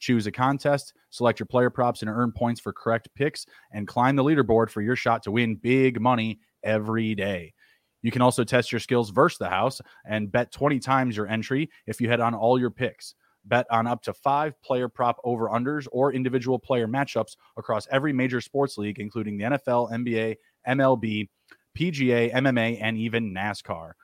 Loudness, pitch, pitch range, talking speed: -25 LUFS, 120 Hz, 110-130 Hz, 190 wpm